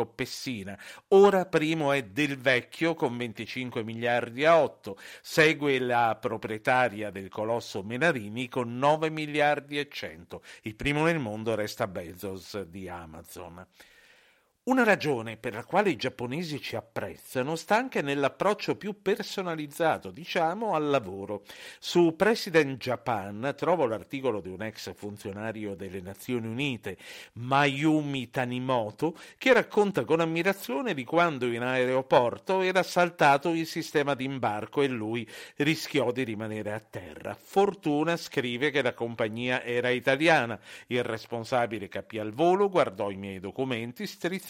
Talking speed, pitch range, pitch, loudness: 135 wpm, 115-160 Hz, 130 Hz, -28 LUFS